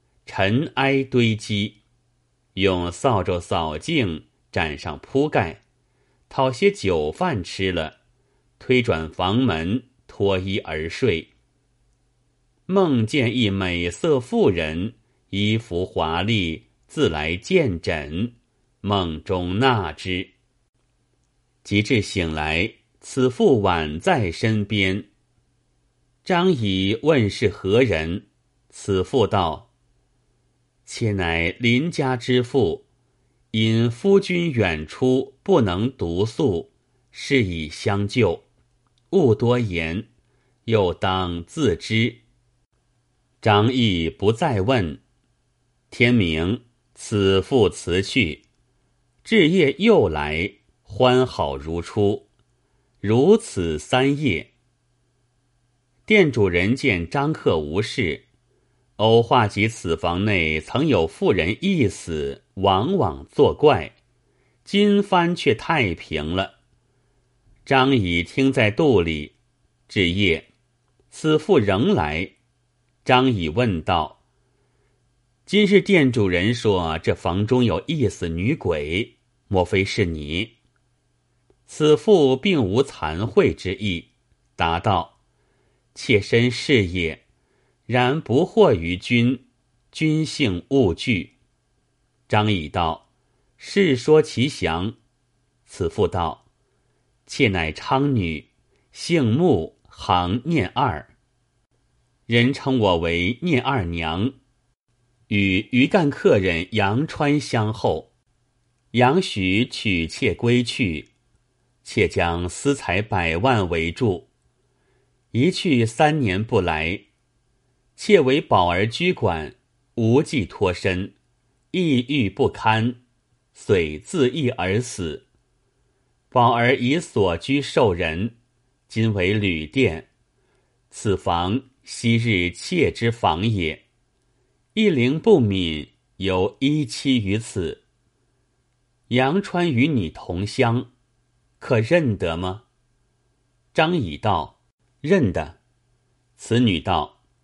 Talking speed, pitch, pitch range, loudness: 130 characters per minute, 120 Hz, 100-130 Hz, -21 LUFS